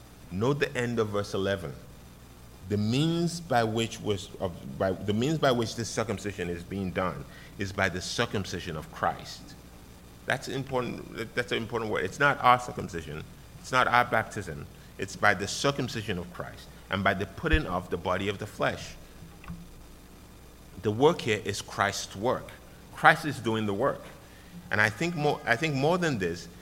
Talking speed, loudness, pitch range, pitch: 175 wpm, -29 LUFS, 90-120 Hz, 105 Hz